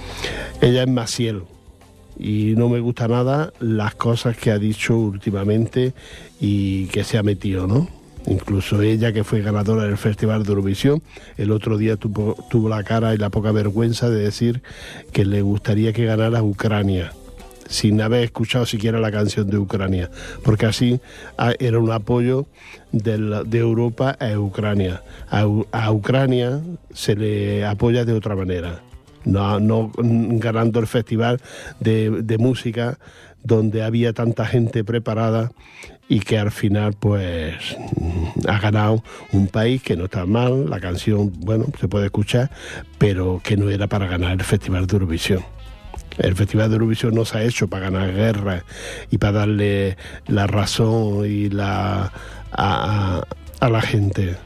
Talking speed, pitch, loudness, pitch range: 155 wpm, 110 Hz, -20 LUFS, 100-115 Hz